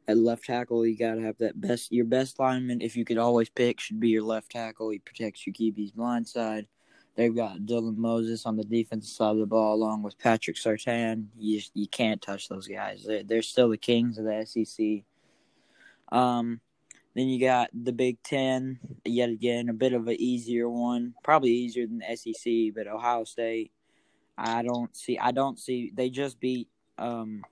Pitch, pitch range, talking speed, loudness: 115 Hz, 110-120 Hz, 195 wpm, -28 LUFS